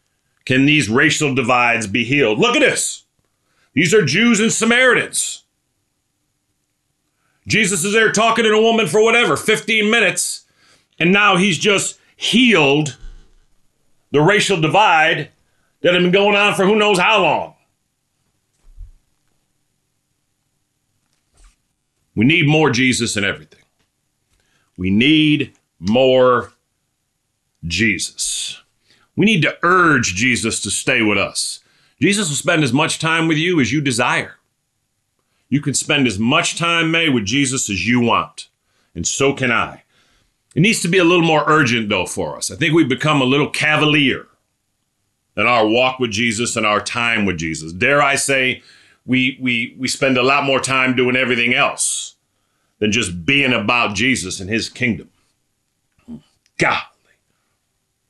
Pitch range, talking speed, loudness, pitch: 120-165 Hz, 145 wpm, -15 LUFS, 135 Hz